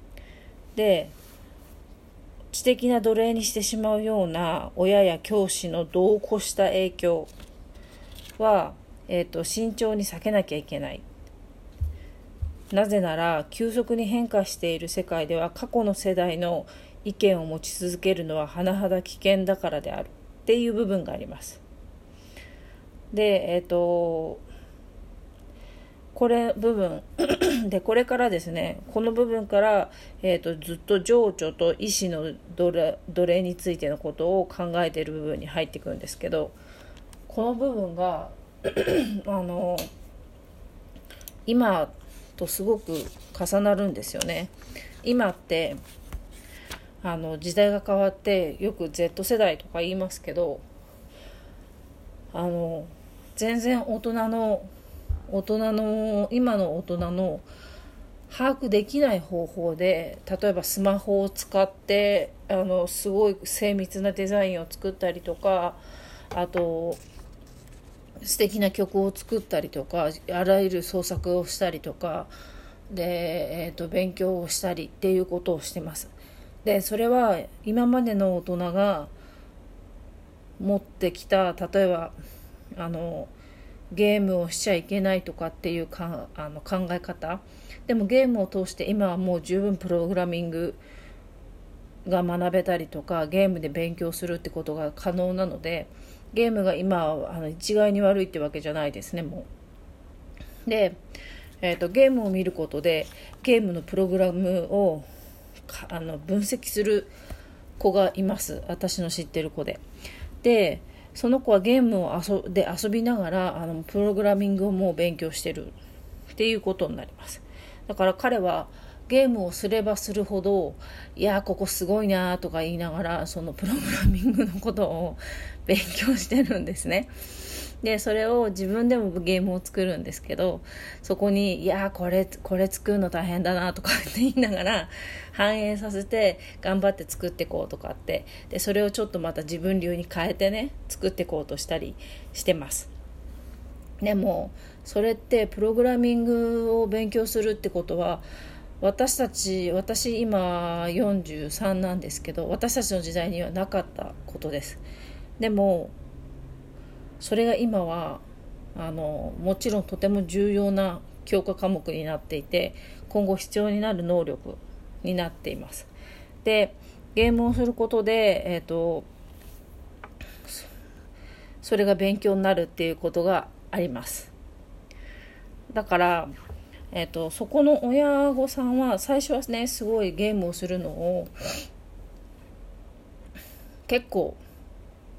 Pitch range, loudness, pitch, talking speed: 155-205 Hz, -26 LUFS, 180 Hz, 265 characters per minute